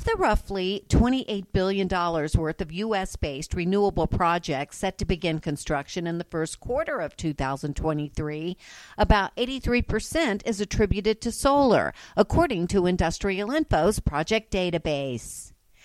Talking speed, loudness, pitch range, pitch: 125 wpm, -26 LUFS, 160-210 Hz, 185 Hz